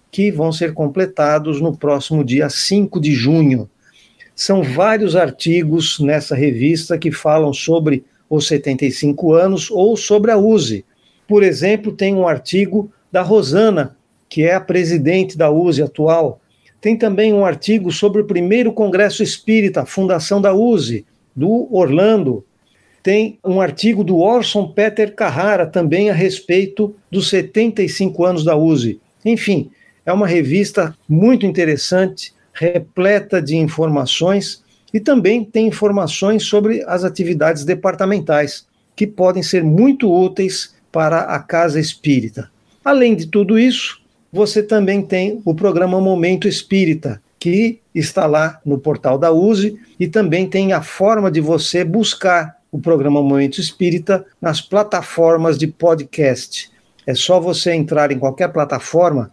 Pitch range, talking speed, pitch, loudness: 155-205 Hz, 140 wpm, 180 Hz, -15 LUFS